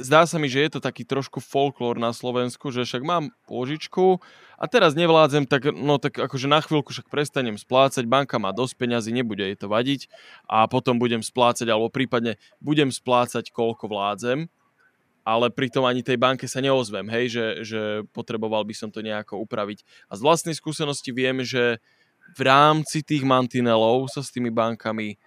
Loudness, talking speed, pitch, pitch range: -23 LUFS, 180 wpm, 125 Hz, 115-145 Hz